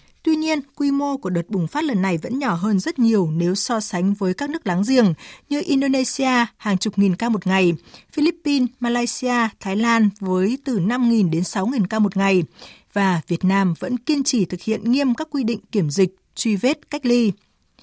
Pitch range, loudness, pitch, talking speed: 190-260 Hz, -20 LUFS, 220 Hz, 205 wpm